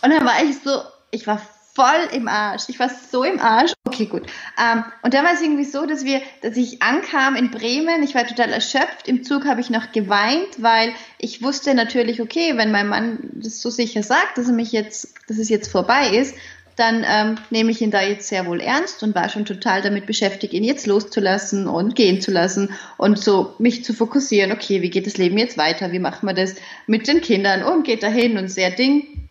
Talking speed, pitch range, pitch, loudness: 225 wpm, 210-265 Hz, 230 Hz, -19 LUFS